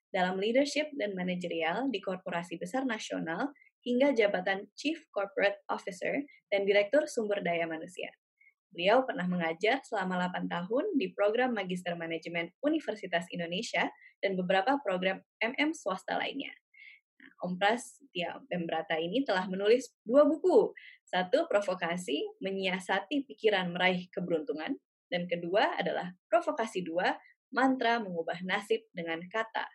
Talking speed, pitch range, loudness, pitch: 125 wpm, 180-270 Hz, -32 LUFS, 200 Hz